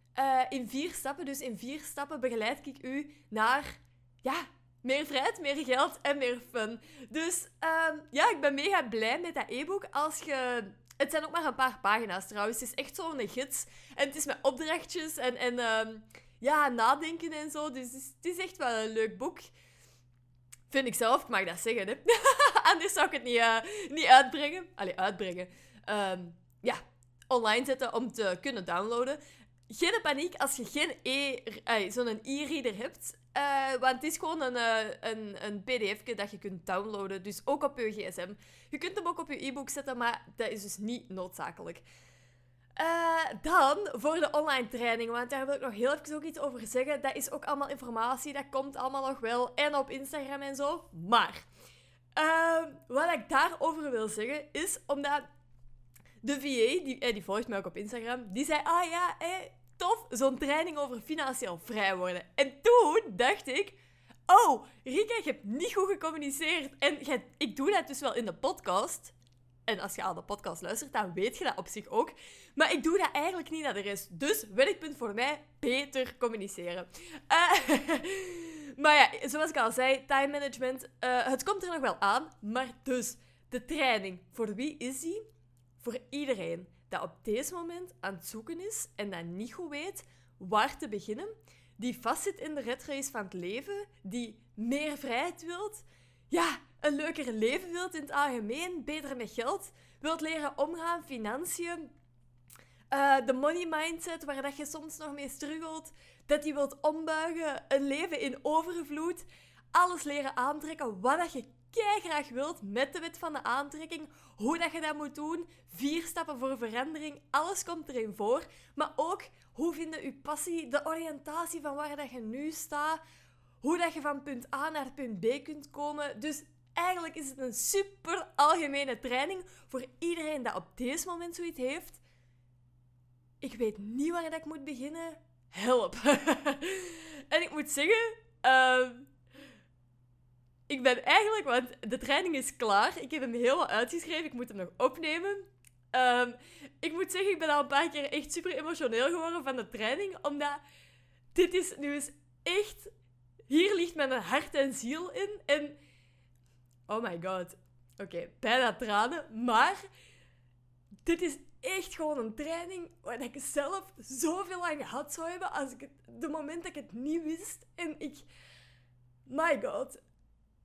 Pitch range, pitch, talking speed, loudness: 225-315 Hz, 275 Hz, 180 wpm, -32 LUFS